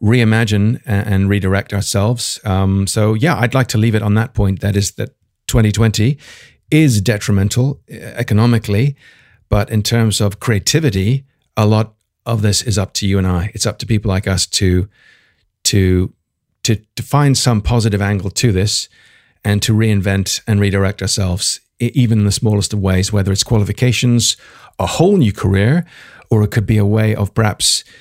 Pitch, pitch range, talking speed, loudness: 105 Hz, 100-115 Hz, 170 wpm, -15 LUFS